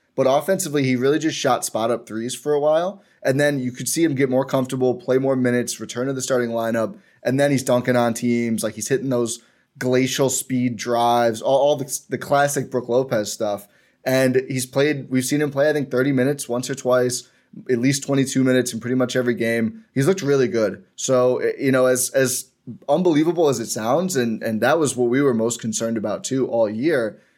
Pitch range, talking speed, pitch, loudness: 120-140 Hz, 215 wpm, 130 Hz, -21 LUFS